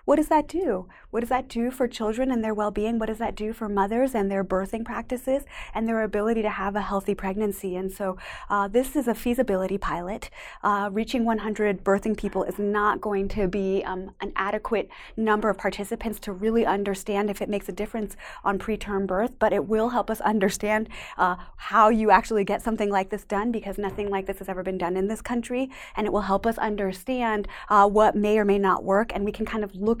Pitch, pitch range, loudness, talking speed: 210 Hz, 195-225 Hz, -25 LUFS, 225 wpm